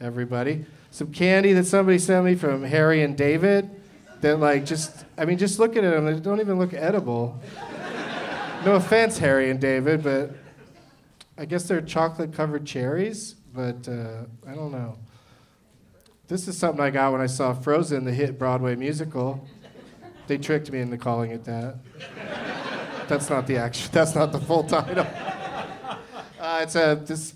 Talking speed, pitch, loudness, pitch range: 160 wpm, 150 Hz, -24 LUFS, 130-175 Hz